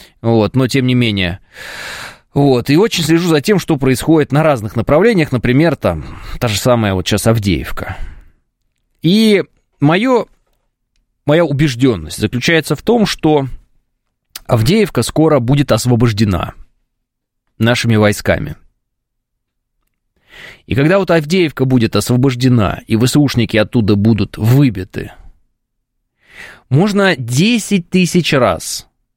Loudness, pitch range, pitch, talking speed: -13 LUFS, 115-155 Hz, 130 Hz, 110 wpm